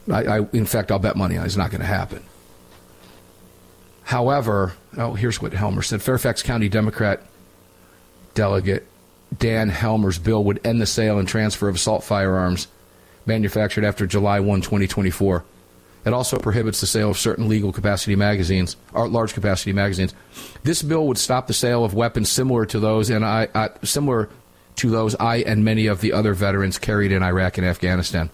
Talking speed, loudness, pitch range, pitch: 175 wpm, -21 LUFS, 95-110 Hz, 105 Hz